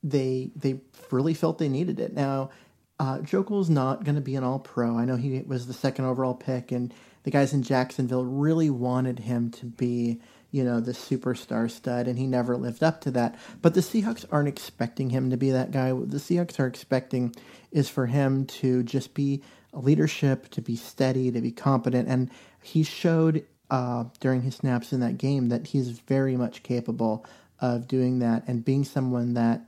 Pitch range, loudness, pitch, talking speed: 125-140 Hz, -27 LUFS, 130 Hz, 195 wpm